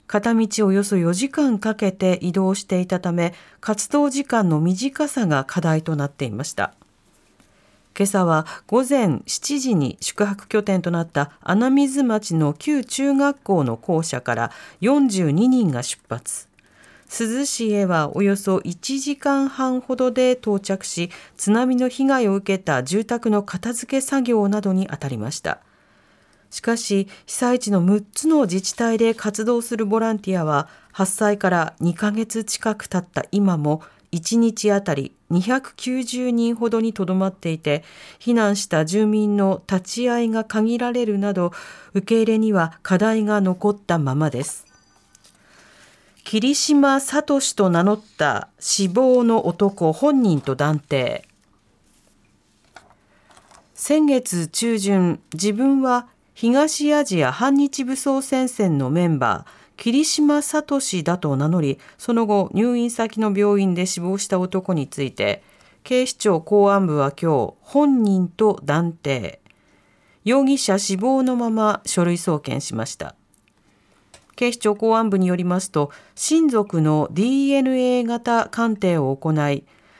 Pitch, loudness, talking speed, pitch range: 205 Hz, -20 LUFS, 240 characters per minute, 170-245 Hz